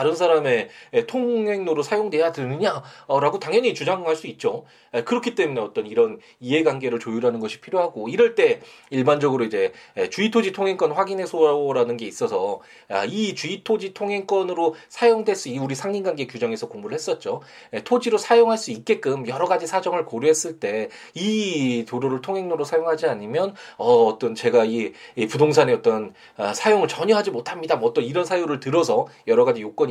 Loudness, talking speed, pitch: -22 LUFS, 375 characters per minute, 200 Hz